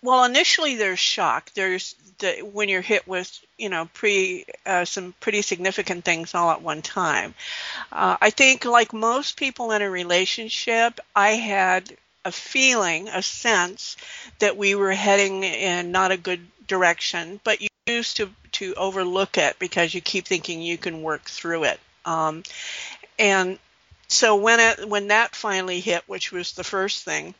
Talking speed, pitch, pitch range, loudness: 165 wpm, 195 Hz, 180-220 Hz, -21 LUFS